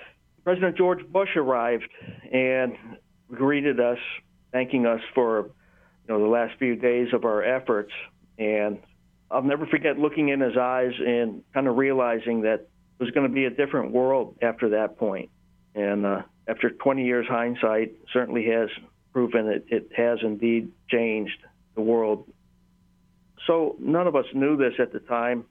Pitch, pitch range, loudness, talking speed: 120 Hz, 110-130 Hz, -25 LUFS, 160 wpm